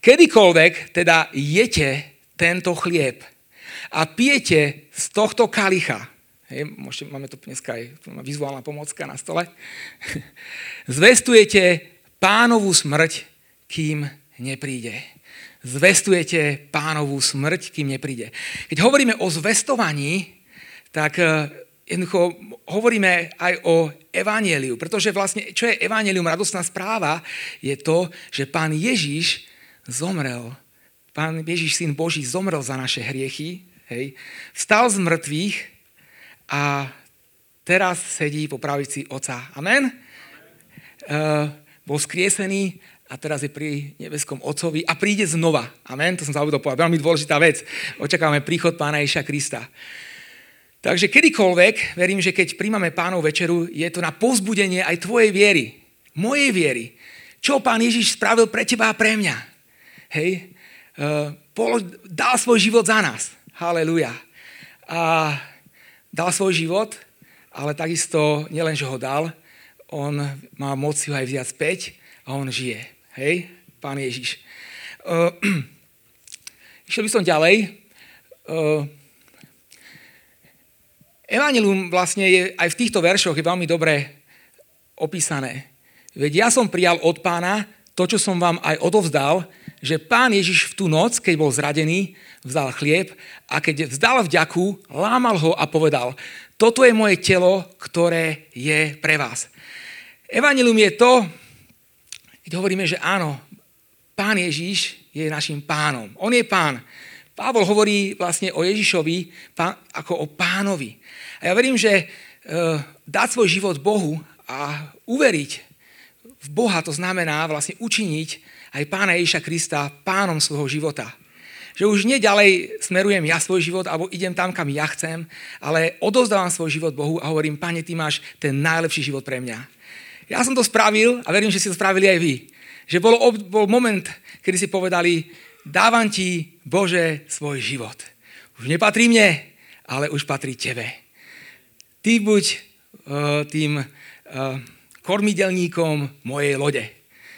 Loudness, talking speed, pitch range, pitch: -19 LUFS, 130 wpm, 150-195 Hz, 170 Hz